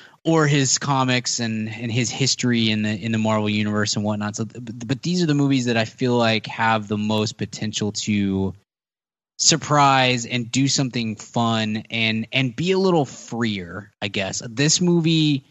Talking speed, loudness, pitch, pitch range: 180 wpm, -21 LUFS, 115 Hz, 110-135 Hz